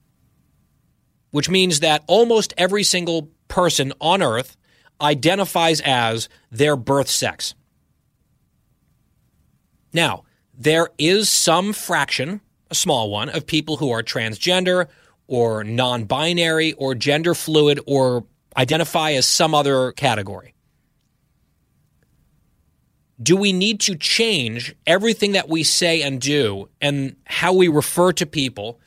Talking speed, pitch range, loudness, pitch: 115 wpm, 130-175 Hz, -18 LUFS, 155 Hz